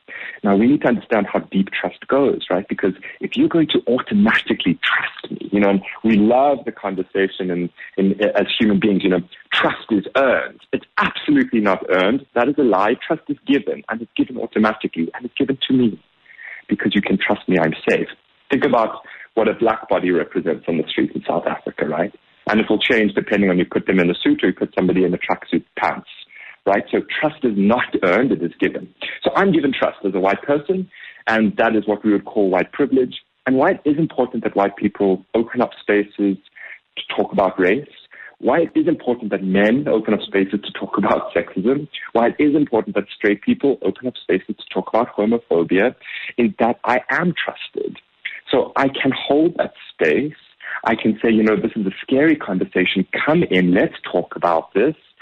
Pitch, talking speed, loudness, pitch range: 115 Hz, 210 wpm, -19 LUFS, 100-145 Hz